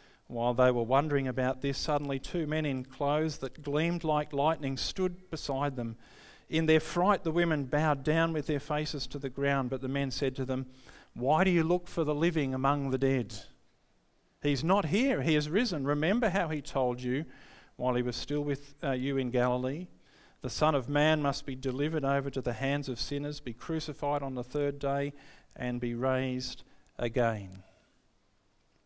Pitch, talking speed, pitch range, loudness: 140 Hz, 185 wpm, 130-155 Hz, -31 LUFS